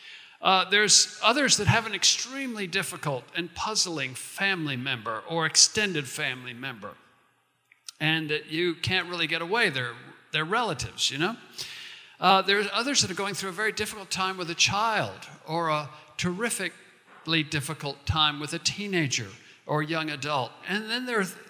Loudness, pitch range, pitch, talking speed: -25 LUFS, 150-205 Hz, 175 Hz, 160 wpm